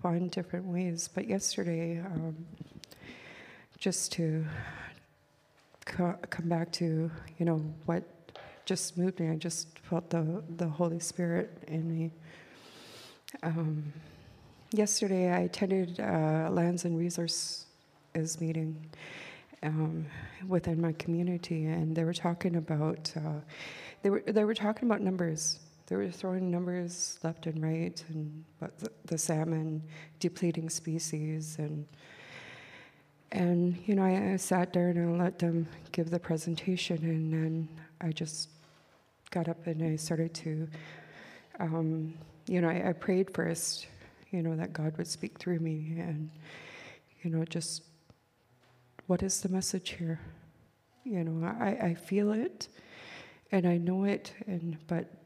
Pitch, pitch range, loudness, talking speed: 165 Hz, 160-180 Hz, -33 LUFS, 140 wpm